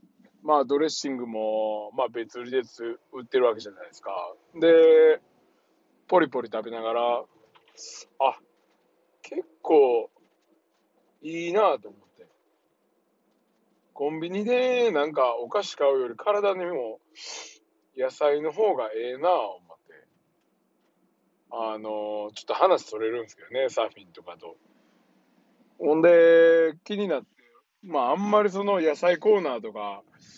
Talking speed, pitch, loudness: 240 characters per minute, 160 Hz, -24 LUFS